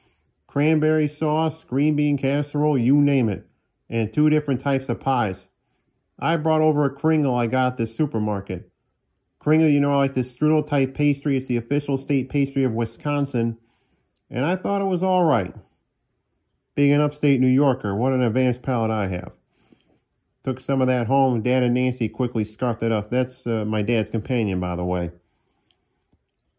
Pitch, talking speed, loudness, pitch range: 130 Hz, 175 wpm, -22 LUFS, 115-145 Hz